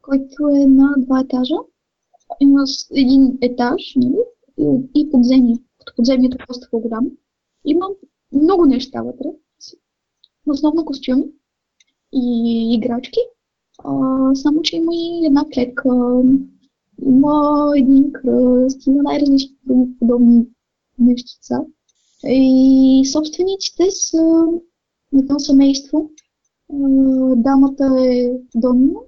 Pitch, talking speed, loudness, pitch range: 270 Hz, 95 wpm, -15 LUFS, 255-300 Hz